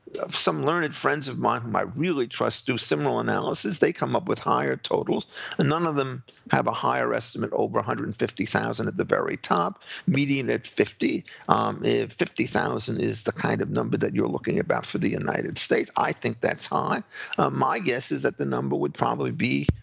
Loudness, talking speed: -26 LUFS, 220 wpm